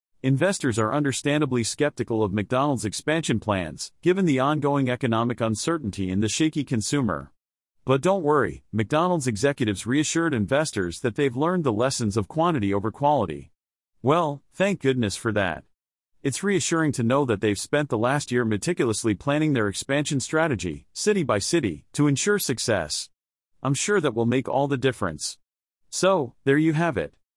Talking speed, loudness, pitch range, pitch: 160 wpm, -24 LUFS, 105-150 Hz, 130 Hz